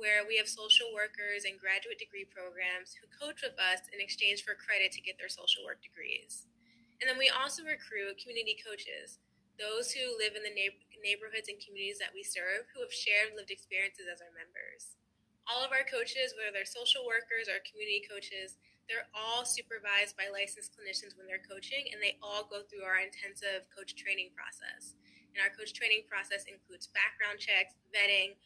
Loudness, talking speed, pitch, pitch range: -34 LUFS, 185 wpm, 210 Hz, 195-260 Hz